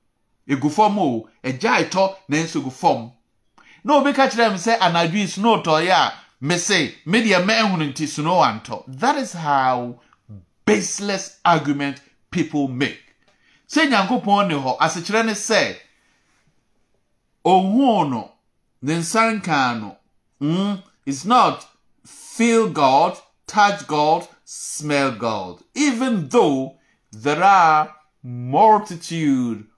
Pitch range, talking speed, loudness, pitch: 140-210 Hz, 115 wpm, -19 LUFS, 165 Hz